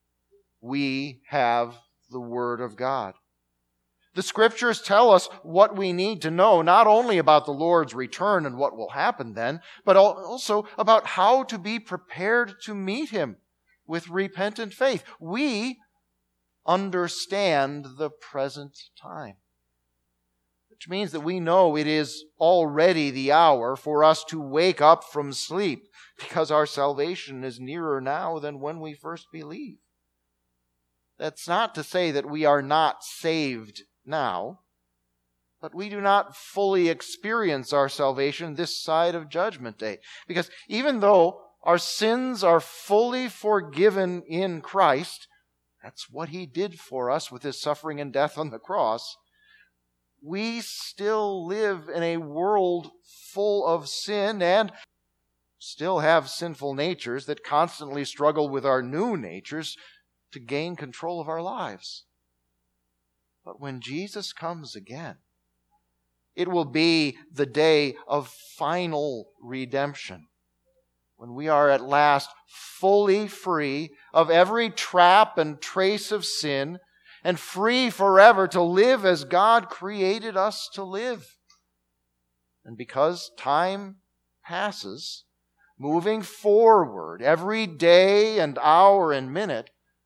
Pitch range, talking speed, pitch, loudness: 130-190 Hz, 130 wpm, 160 Hz, -23 LUFS